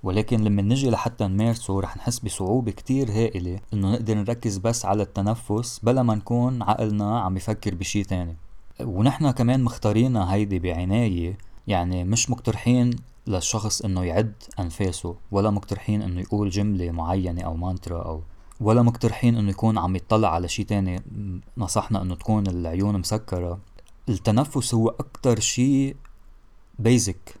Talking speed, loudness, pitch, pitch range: 140 wpm, -24 LUFS, 105 Hz, 95-115 Hz